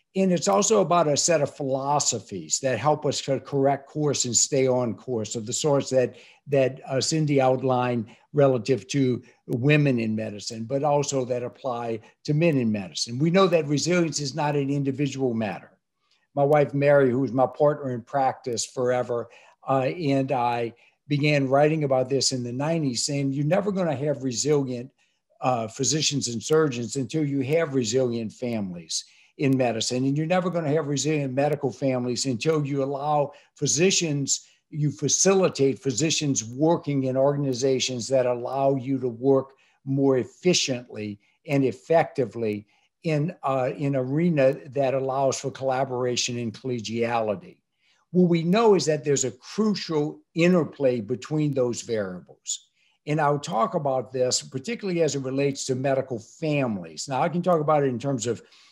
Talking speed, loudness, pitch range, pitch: 160 wpm, -24 LUFS, 125-150 Hz, 135 Hz